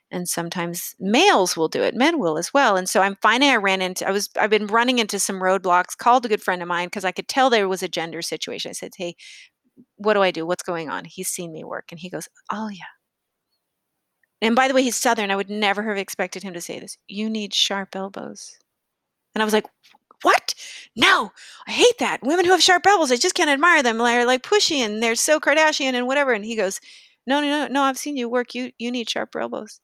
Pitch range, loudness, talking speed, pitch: 190-265 Hz, -20 LUFS, 245 wpm, 220 Hz